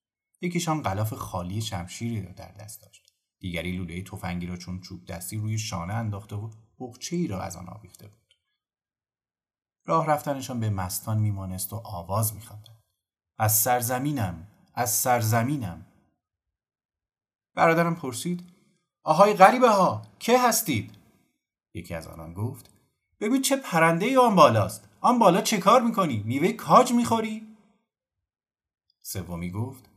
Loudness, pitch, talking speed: -24 LUFS, 110 Hz, 130 wpm